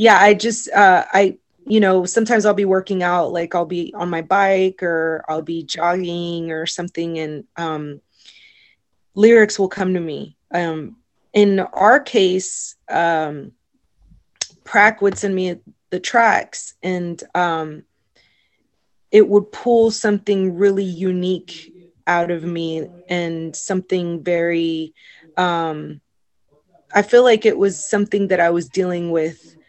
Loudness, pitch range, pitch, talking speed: -18 LUFS, 165-200 Hz, 180 Hz, 135 wpm